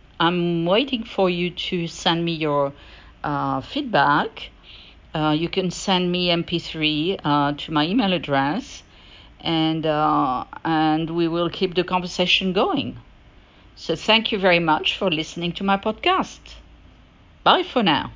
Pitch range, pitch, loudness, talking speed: 155-190 Hz, 170 Hz, -21 LUFS, 140 wpm